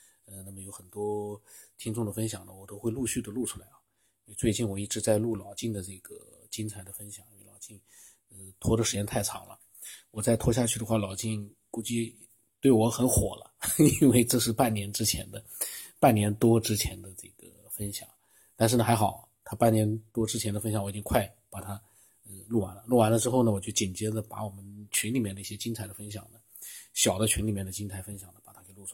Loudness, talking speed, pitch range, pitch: -28 LUFS, 310 characters per minute, 100-115 Hz, 110 Hz